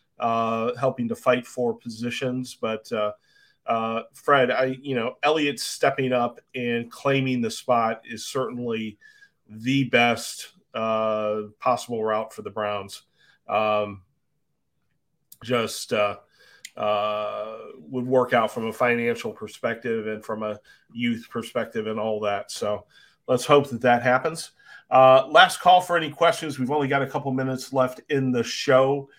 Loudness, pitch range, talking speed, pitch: -24 LUFS, 110-135 Hz, 145 wpm, 125 Hz